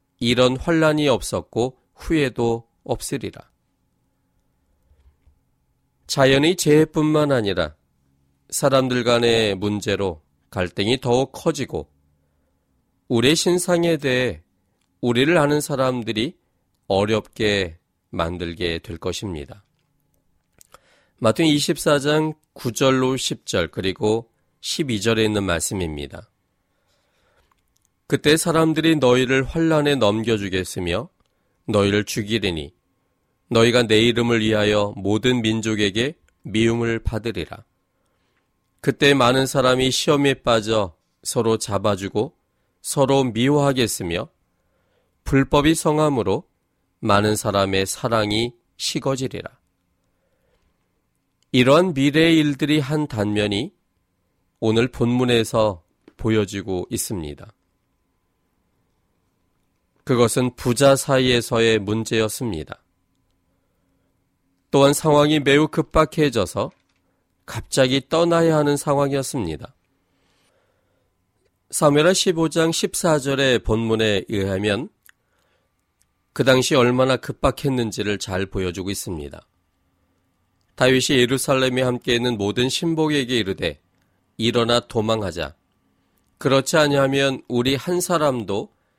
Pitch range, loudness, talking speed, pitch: 95-140 Hz, -20 LUFS, 215 characters per minute, 115 Hz